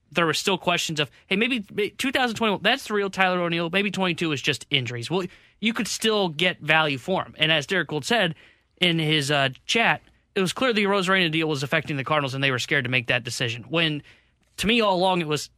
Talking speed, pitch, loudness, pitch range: 230 wpm, 170 Hz, -23 LUFS, 145-195 Hz